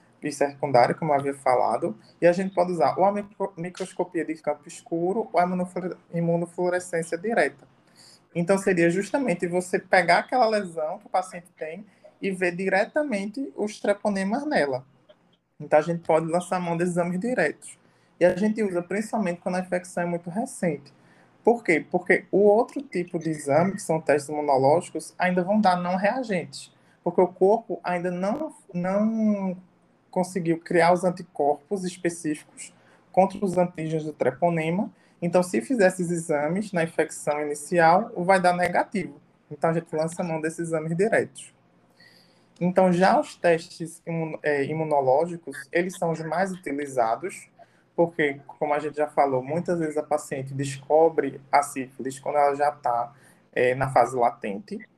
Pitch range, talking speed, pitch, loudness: 155-190 Hz, 155 wpm, 175 Hz, -25 LUFS